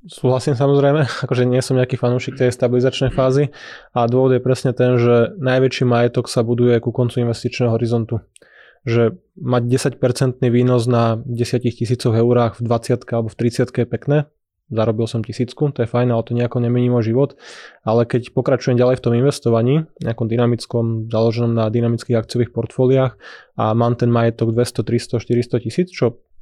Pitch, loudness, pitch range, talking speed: 120 Hz, -18 LUFS, 115-130 Hz, 170 wpm